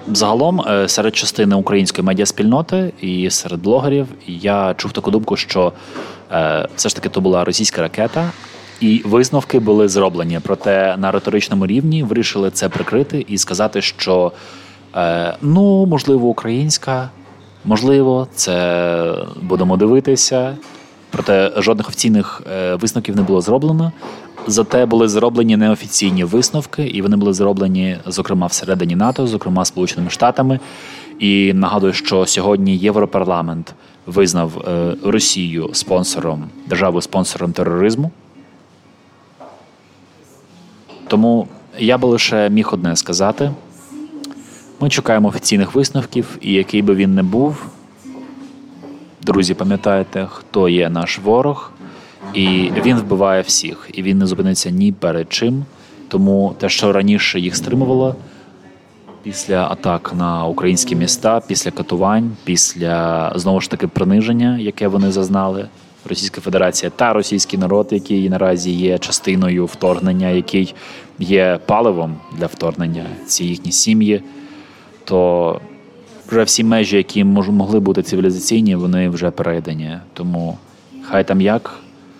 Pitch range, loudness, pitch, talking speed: 90-120 Hz, -15 LUFS, 100 Hz, 120 wpm